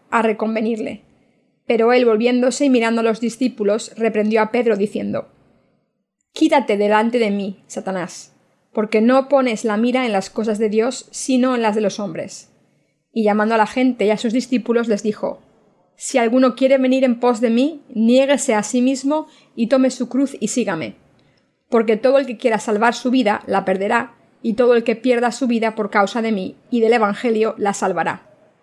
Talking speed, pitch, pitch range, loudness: 190 wpm, 230 Hz, 215-255 Hz, -18 LUFS